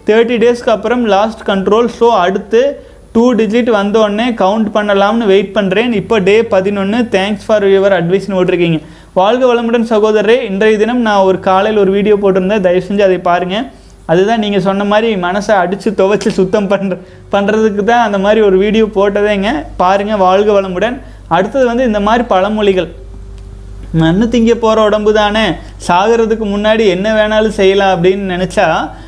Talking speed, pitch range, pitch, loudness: 150 wpm, 190-220 Hz, 210 Hz, -11 LUFS